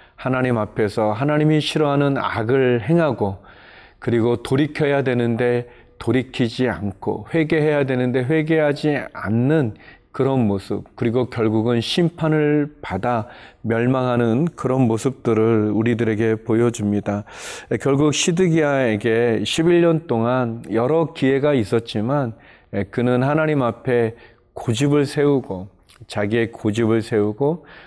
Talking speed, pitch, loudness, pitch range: 270 characters per minute, 125 Hz, -20 LUFS, 115-145 Hz